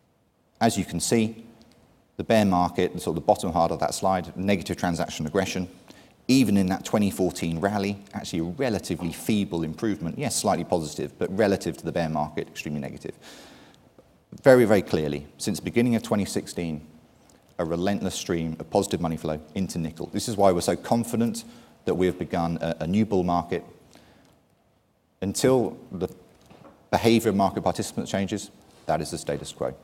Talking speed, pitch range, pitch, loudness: 165 wpm, 85-110 Hz, 95 Hz, -25 LUFS